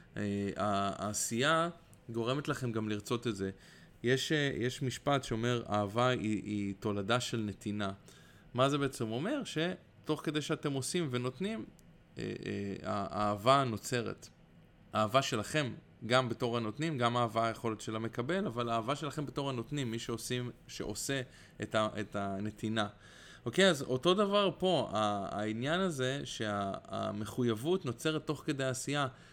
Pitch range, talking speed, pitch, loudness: 105-145 Hz, 135 wpm, 120 Hz, -34 LUFS